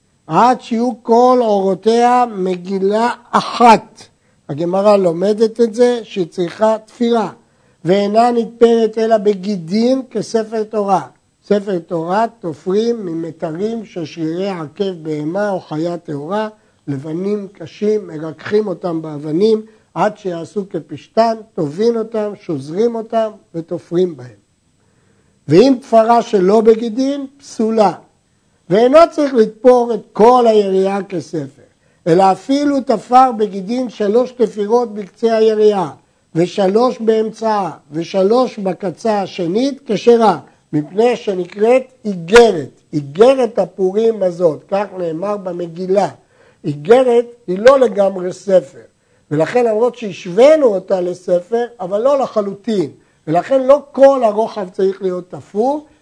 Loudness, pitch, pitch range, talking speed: -15 LUFS, 210 Hz, 180-230 Hz, 105 wpm